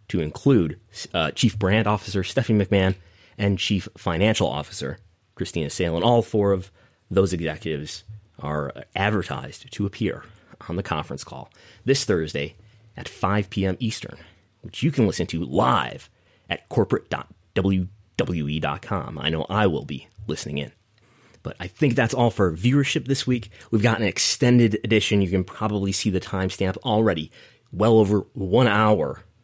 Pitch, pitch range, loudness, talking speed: 100 Hz, 90-110 Hz, -23 LUFS, 150 wpm